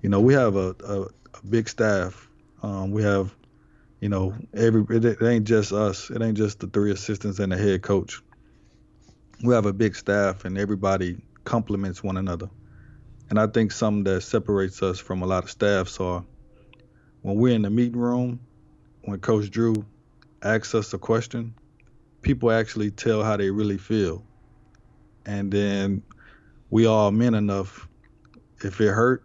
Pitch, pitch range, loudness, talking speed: 105 Hz, 95-115 Hz, -24 LUFS, 165 wpm